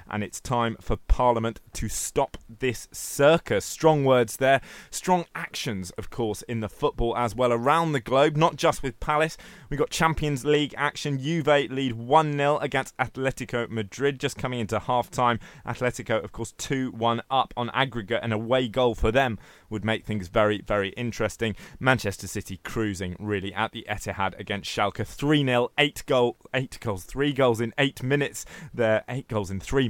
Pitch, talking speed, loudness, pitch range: 120 Hz, 175 wpm, -26 LUFS, 110-140 Hz